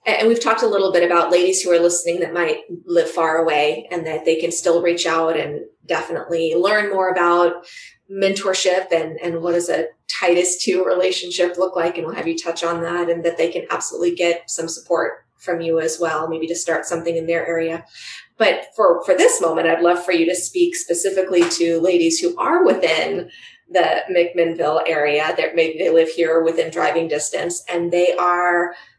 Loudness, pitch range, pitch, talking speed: -18 LUFS, 165-180 Hz, 170 Hz, 200 wpm